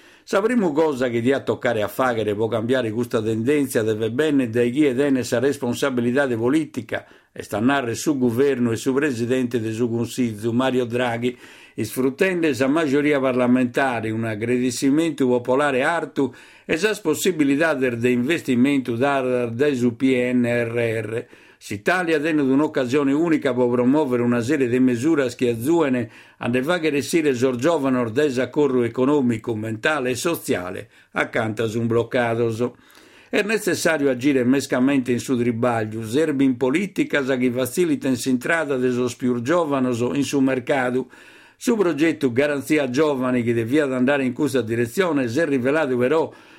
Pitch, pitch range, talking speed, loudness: 130 Hz, 120-145 Hz, 150 wpm, -21 LUFS